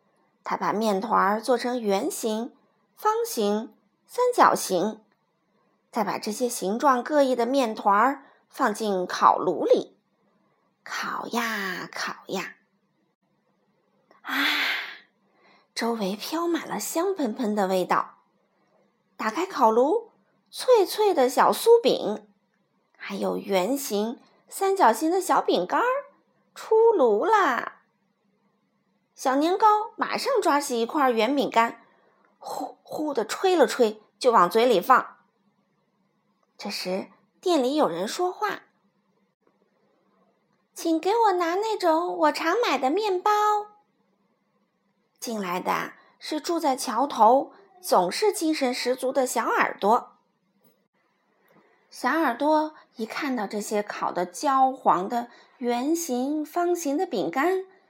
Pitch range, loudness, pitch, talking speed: 220-360 Hz, -24 LUFS, 265 Hz, 160 characters per minute